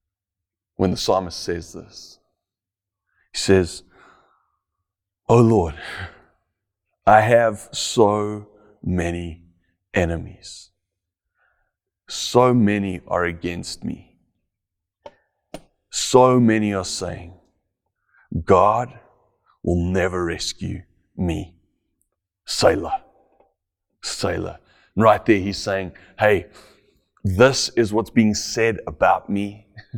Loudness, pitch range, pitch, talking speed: -20 LUFS, 90-105 Hz, 95 Hz, 85 wpm